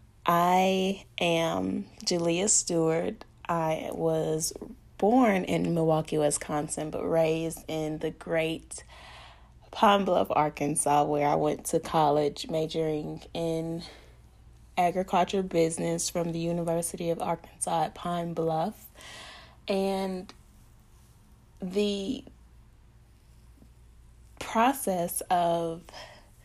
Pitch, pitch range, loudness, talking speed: 165 Hz, 150-175 Hz, -28 LUFS, 90 wpm